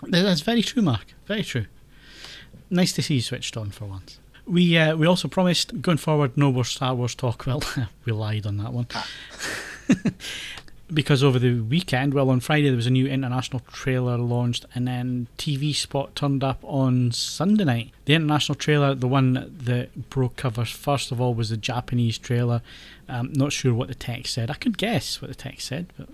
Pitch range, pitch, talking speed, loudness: 125-150 Hz, 130 Hz, 195 wpm, -24 LUFS